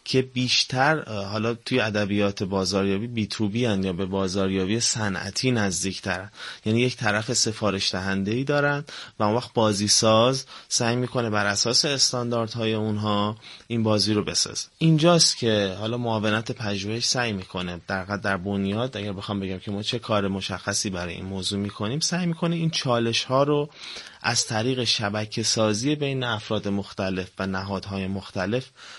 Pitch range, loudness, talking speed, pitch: 100-120 Hz, -24 LUFS, 150 wpm, 105 Hz